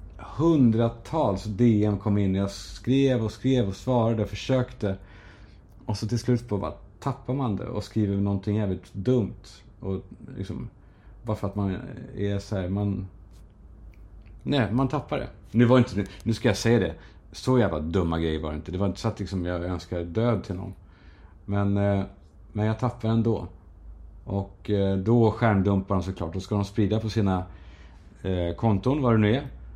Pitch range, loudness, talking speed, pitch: 95-115 Hz, -26 LUFS, 175 wpm, 100 Hz